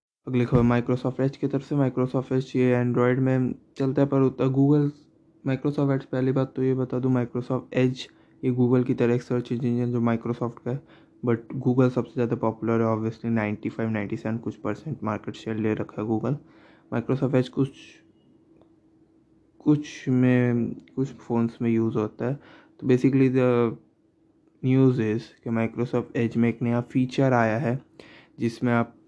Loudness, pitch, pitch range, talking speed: -25 LUFS, 125 Hz, 115-130 Hz, 170 wpm